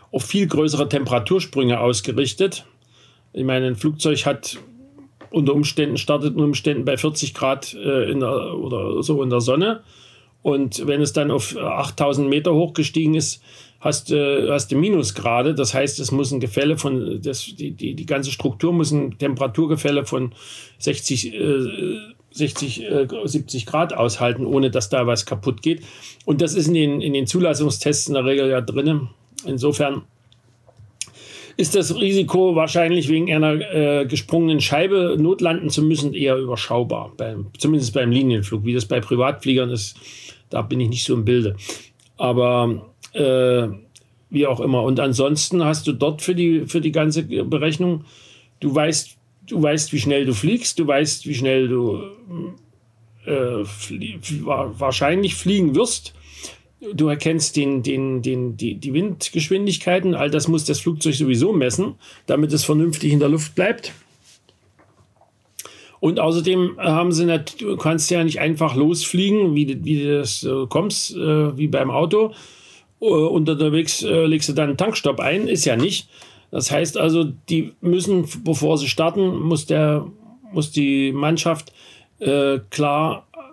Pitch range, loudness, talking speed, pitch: 130-160 Hz, -20 LUFS, 150 wpm, 145 Hz